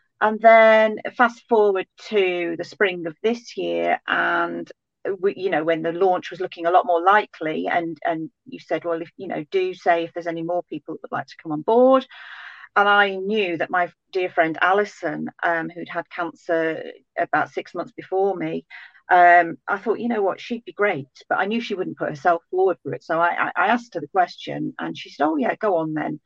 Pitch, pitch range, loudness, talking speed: 180 Hz, 170-215 Hz, -21 LUFS, 220 wpm